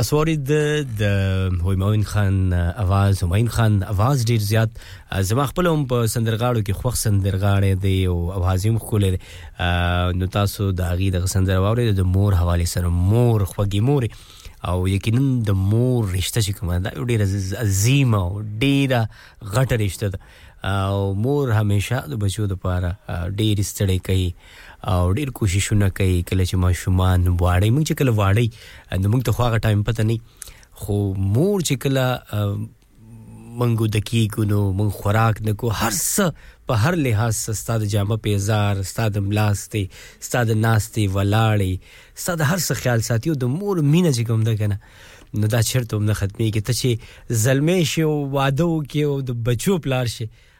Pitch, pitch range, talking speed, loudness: 105 Hz, 95-120 Hz, 160 wpm, -20 LUFS